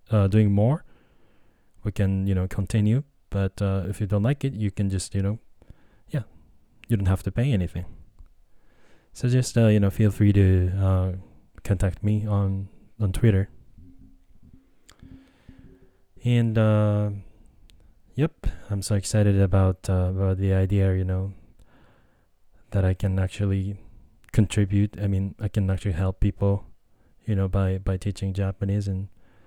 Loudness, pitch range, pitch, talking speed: -24 LUFS, 95-105 Hz, 100 Hz, 150 wpm